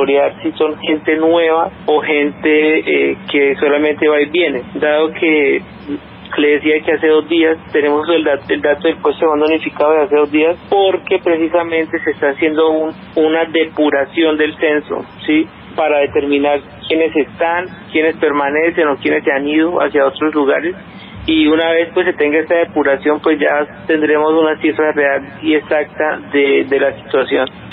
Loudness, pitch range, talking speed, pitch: -14 LUFS, 150-165 Hz, 170 wpm, 155 Hz